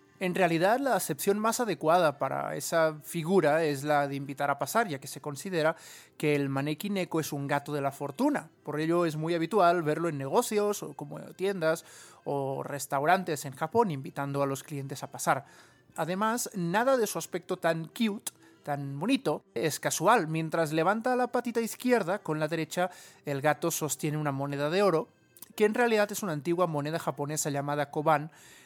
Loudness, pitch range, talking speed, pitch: -29 LUFS, 145-190 Hz, 180 wpm, 160 Hz